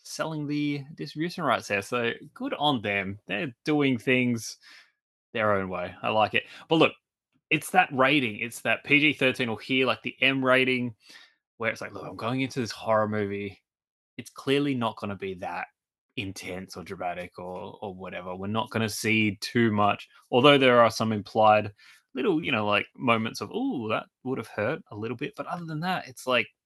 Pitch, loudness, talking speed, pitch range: 115 Hz, -26 LUFS, 195 wpm, 105-135 Hz